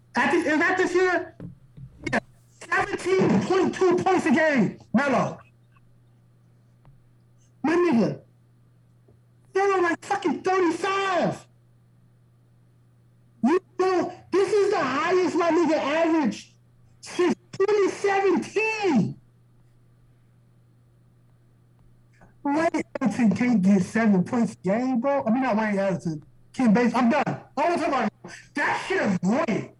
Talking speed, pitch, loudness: 115 wpm, 220 Hz, -23 LUFS